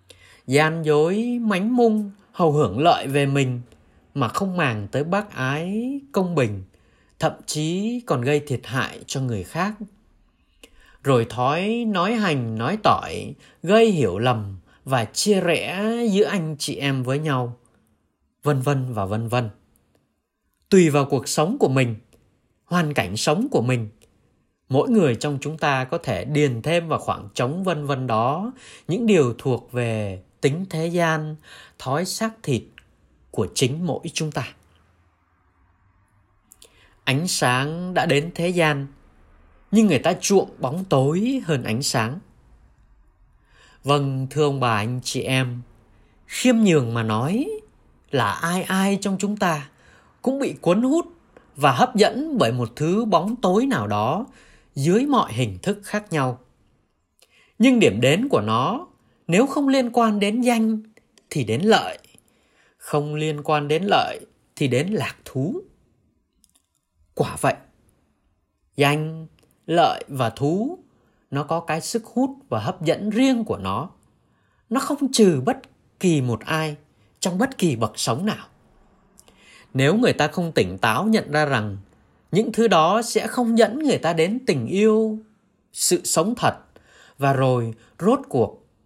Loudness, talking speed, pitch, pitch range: -22 LUFS, 150 wpm, 150 Hz, 125-205 Hz